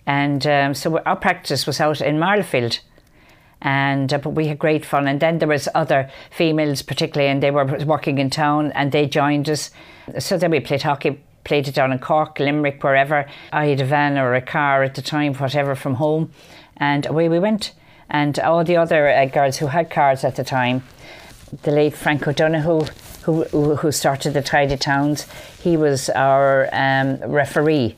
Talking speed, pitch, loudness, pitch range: 190 wpm, 145 Hz, -19 LUFS, 140-155 Hz